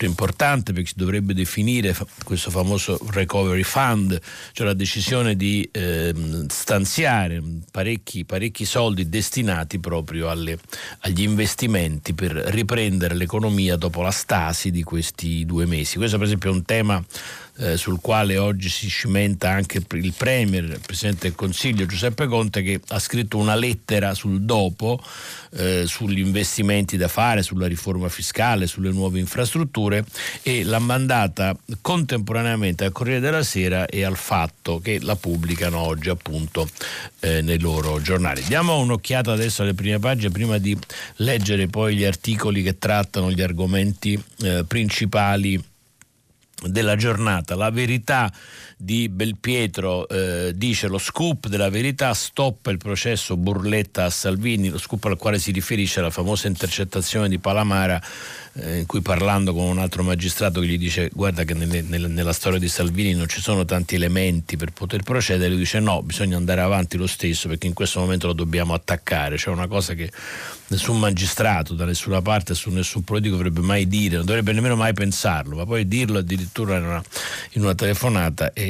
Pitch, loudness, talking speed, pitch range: 95 Hz, -22 LUFS, 160 wpm, 90-105 Hz